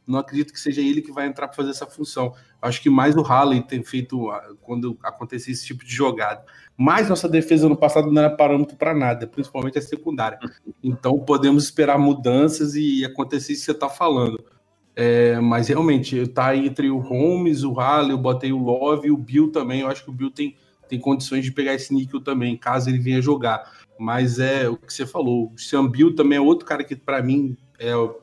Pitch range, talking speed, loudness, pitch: 125-145 Hz, 215 wpm, -20 LUFS, 135 Hz